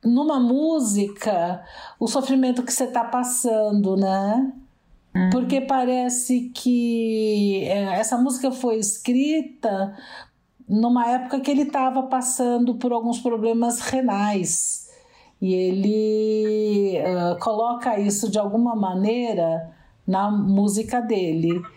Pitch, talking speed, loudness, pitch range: 230 Hz, 100 wpm, -22 LUFS, 200-255 Hz